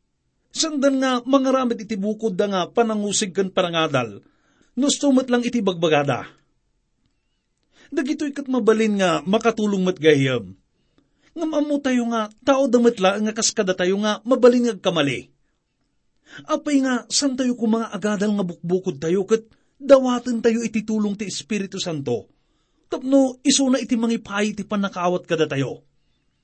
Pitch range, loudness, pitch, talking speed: 185-255 Hz, -21 LUFS, 220 Hz, 125 wpm